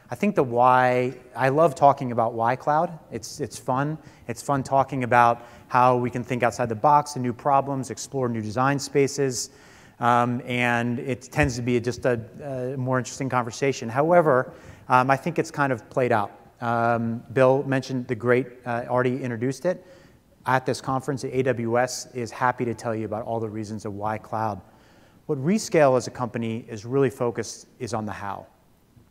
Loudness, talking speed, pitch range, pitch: -24 LUFS, 185 wpm, 115-135 Hz, 125 Hz